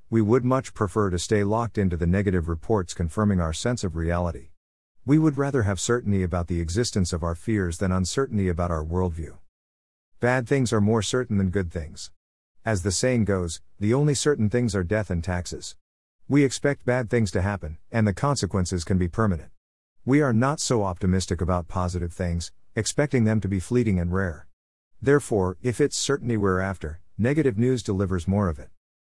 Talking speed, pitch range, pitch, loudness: 190 wpm, 90-120 Hz, 100 Hz, -25 LUFS